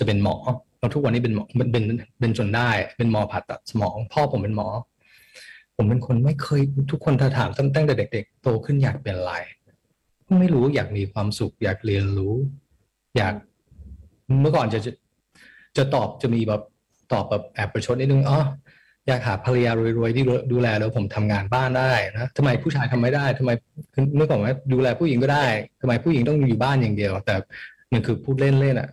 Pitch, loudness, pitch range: 125 Hz, -22 LUFS, 110-135 Hz